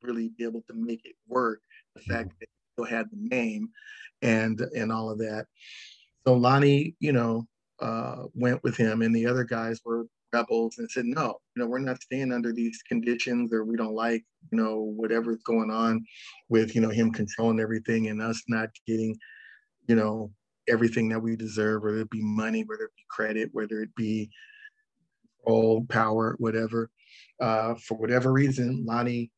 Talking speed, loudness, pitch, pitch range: 180 wpm, -28 LUFS, 115 Hz, 110-125 Hz